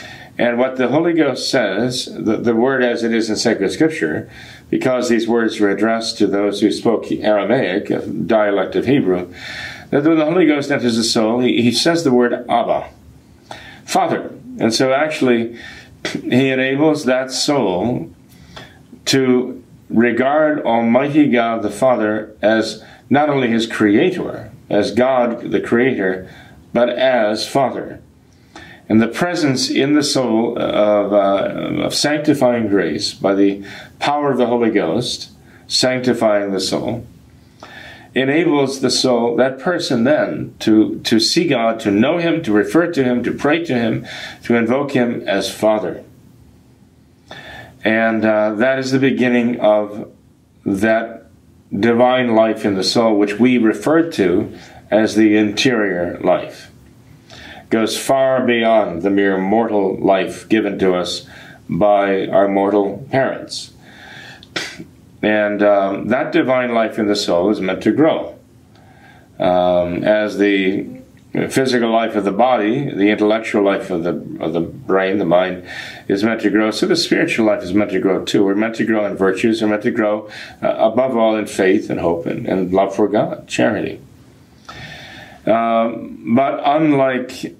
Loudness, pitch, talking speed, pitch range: -16 LUFS, 115 Hz, 150 wpm, 105-125 Hz